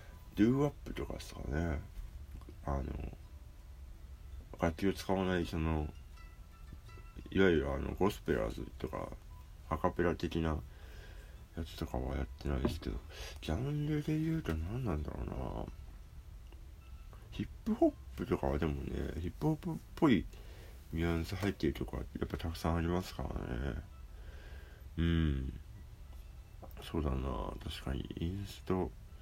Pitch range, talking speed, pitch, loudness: 70-90 Hz, 270 characters per minute, 80 Hz, -37 LUFS